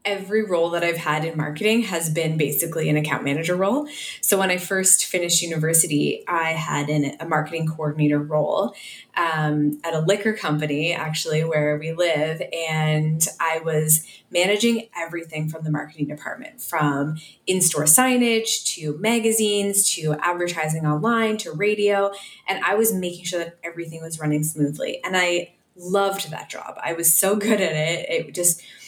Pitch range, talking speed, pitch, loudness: 155-195 Hz, 165 wpm, 165 Hz, -21 LUFS